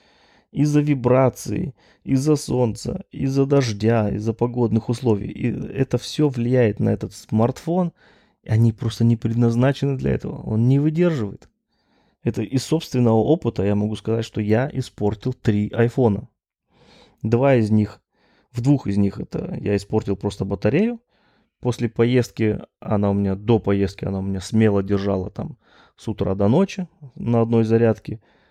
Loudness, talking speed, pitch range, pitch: -21 LUFS, 145 wpm, 105-130 Hz, 115 Hz